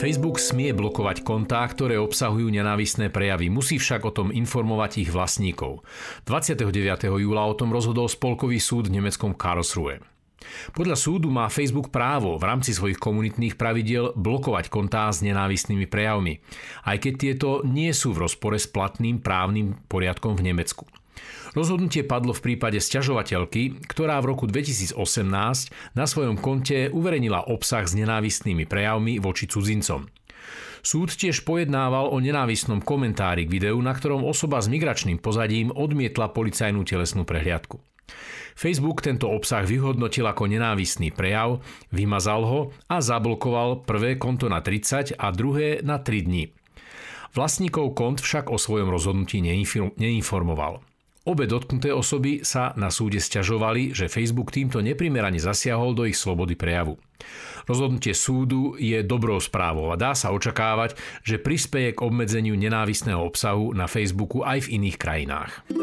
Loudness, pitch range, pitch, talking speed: -24 LUFS, 100-130 Hz, 115 Hz, 140 wpm